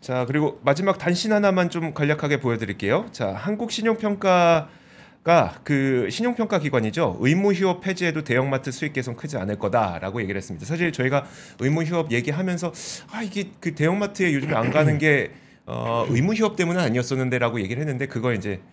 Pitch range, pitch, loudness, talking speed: 125-180 Hz, 150 Hz, -23 LUFS, 405 characters per minute